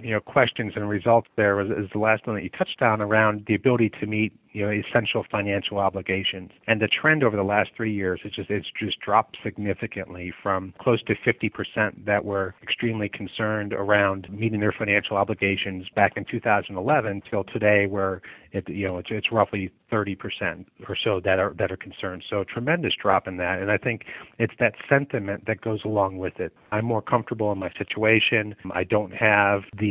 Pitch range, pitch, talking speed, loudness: 100-110 Hz, 105 Hz, 205 wpm, -24 LUFS